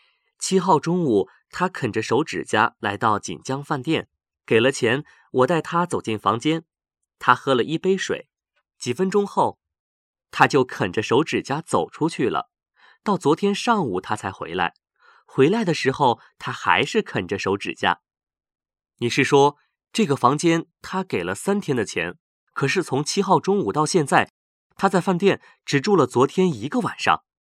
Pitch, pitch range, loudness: 160 Hz, 135-190 Hz, -22 LUFS